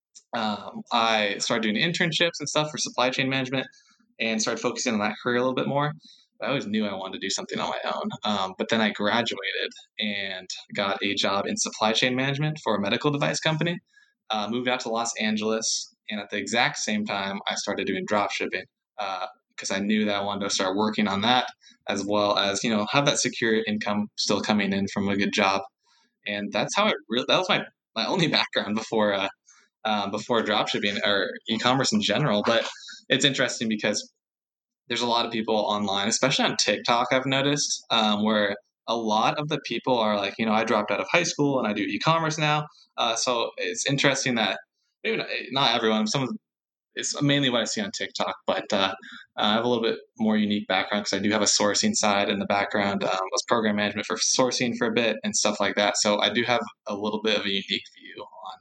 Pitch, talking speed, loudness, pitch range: 110 Hz, 220 wpm, -25 LUFS, 105-135 Hz